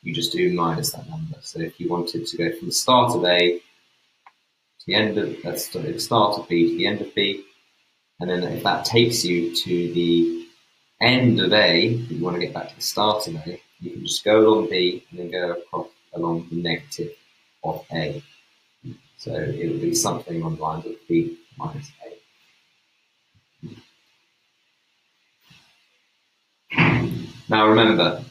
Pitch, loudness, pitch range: 100 Hz, -21 LUFS, 85-125 Hz